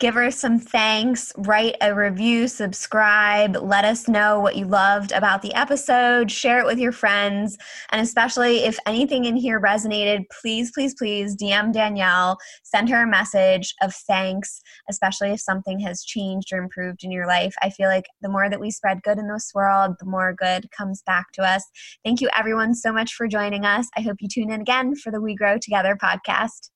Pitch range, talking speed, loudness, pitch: 195-230 Hz, 200 wpm, -20 LUFS, 210 Hz